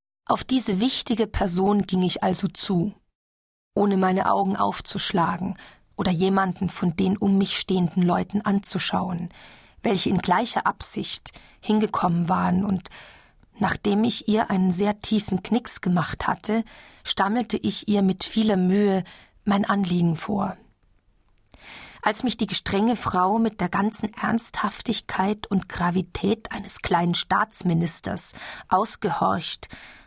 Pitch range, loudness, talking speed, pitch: 185-215 Hz, -23 LUFS, 120 wpm, 195 Hz